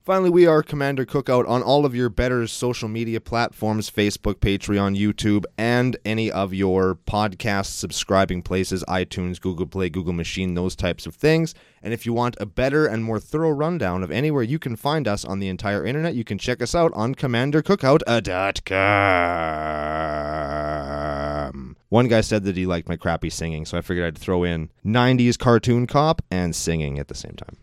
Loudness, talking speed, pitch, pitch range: -22 LUFS, 180 wpm, 105 Hz, 90-125 Hz